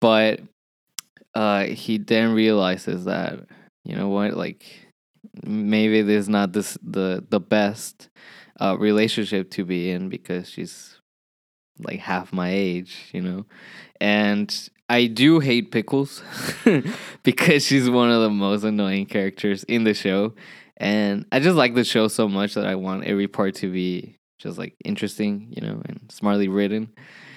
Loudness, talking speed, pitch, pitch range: -22 LUFS, 155 wpm, 105 Hz, 100-115 Hz